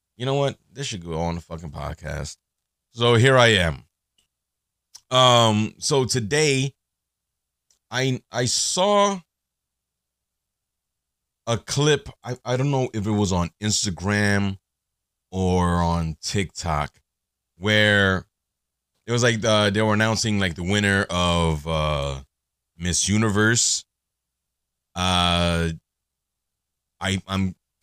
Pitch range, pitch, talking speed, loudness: 80-115 Hz, 95 Hz, 110 wpm, -21 LUFS